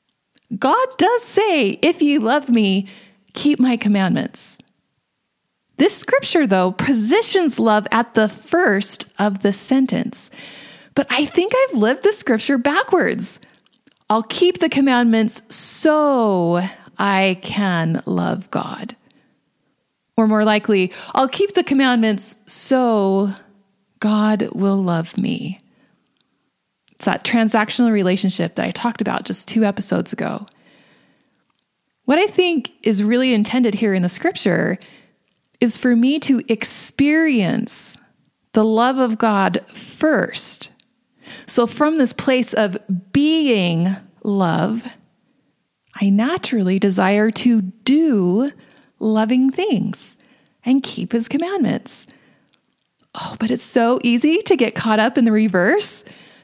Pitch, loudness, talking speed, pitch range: 230 Hz, -18 LUFS, 120 wpm, 205-275 Hz